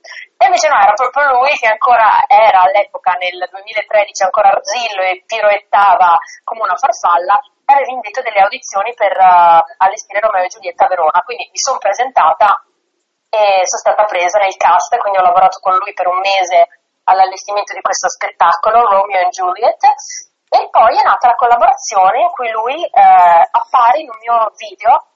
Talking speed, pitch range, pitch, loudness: 170 wpm, 190-270 Hz, 210 Hz, -11 LUFS